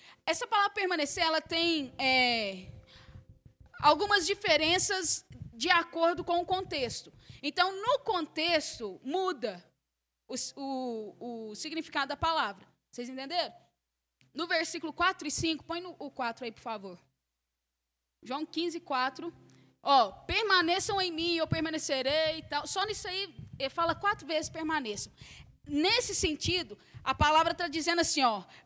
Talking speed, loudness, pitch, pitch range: 135 wpm, -30 LUFS, 320 Hz, 270-355 Hz